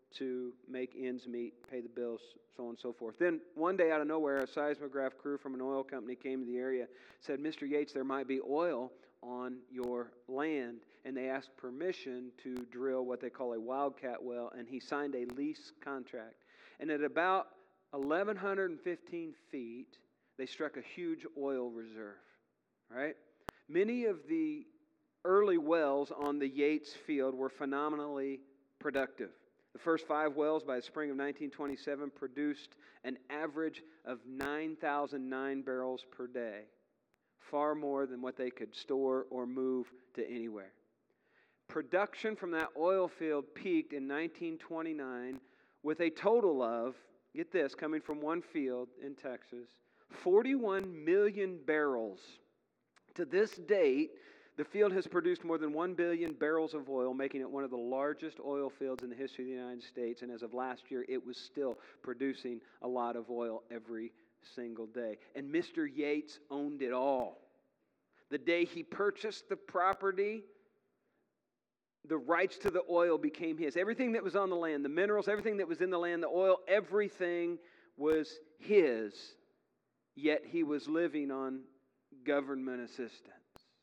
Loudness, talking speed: -37 LUFS, 160 wpm